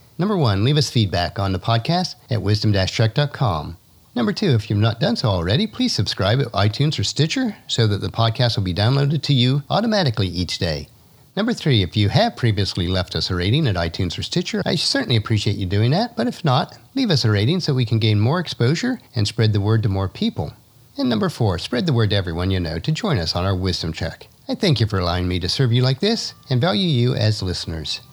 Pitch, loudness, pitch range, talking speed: 115 Hz, -20 LUFS, 100-150 Hz, 235 wpm